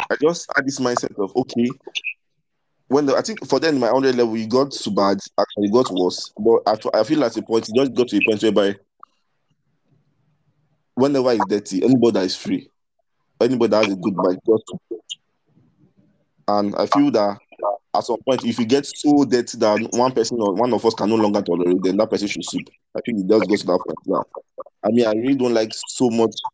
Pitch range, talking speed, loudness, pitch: 105-135 Hz, 235 wpm, -20 LUFS, 115 Hz